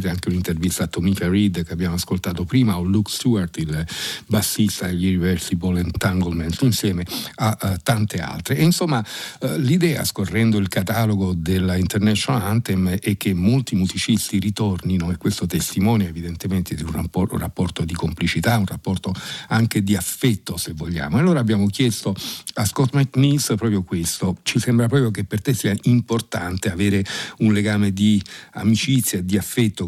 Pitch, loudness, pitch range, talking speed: 100 Hz, -21 LUFS, 90-115 Hz, 155 wpm